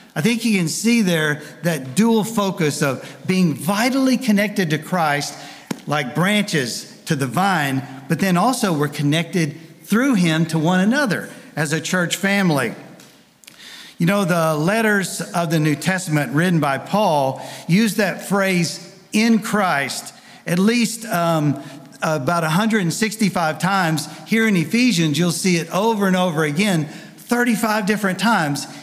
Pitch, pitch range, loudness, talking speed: 180 Hz, 155-210 Hz, -19 LUFS, 145 wpm